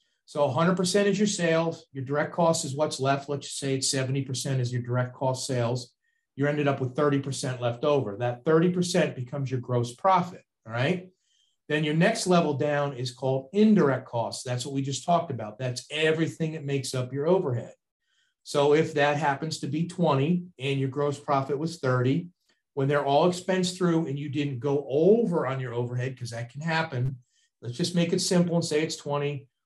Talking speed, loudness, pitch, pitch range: 195 wpm, -27 LUFS, 145 Hz, 130-165 Hz